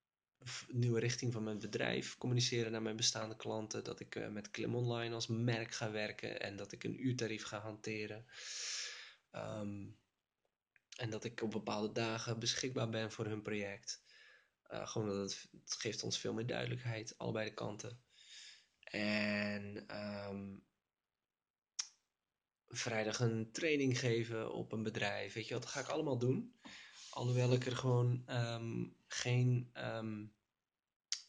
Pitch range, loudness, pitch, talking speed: 105-125 Hz, -40 LUFS, 115 Hz, 140 wpm